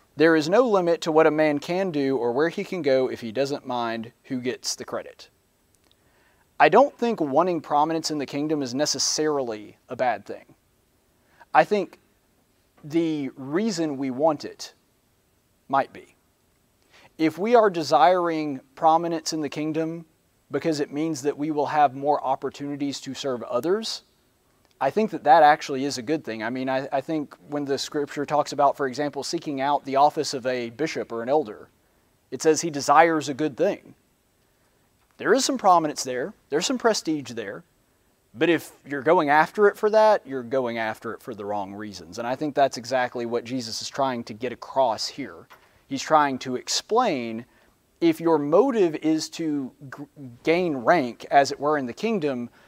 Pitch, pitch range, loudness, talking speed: 145 Hz, 130-160 Hz, -24 LUFS, 180 wpm